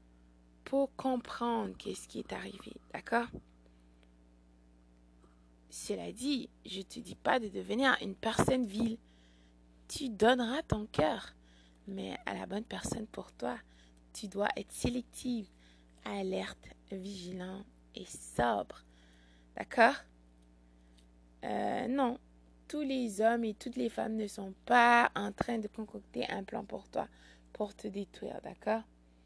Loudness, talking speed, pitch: -35 LUFS, 130 wpm, 185 Hz